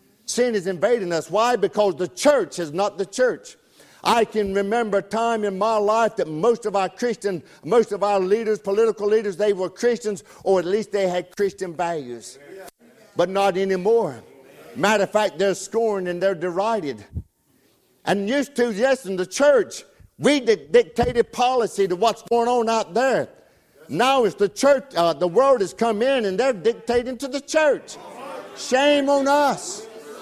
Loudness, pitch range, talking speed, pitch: -21 LUFS, 195-240 Hz, 175 wpm, 215 Hz